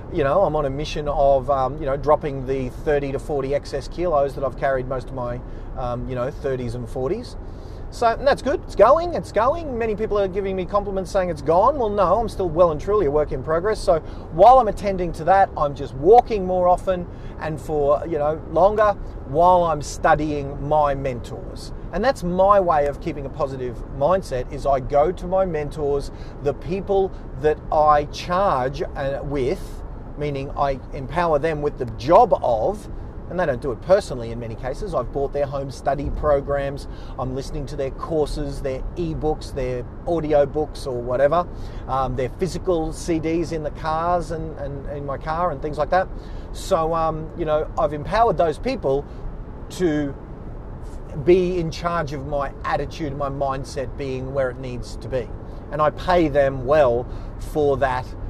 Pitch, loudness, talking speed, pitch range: 145 Hz, -22 LUFS, 185 wpm, 130-170 Hz